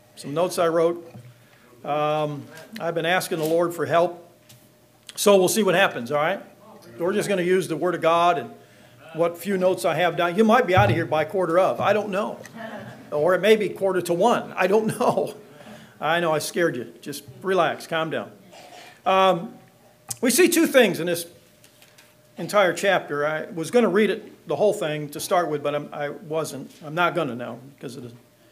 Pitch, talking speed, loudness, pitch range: 170 Hz, 210 wpm, -22 LUFS, 150-190 Hz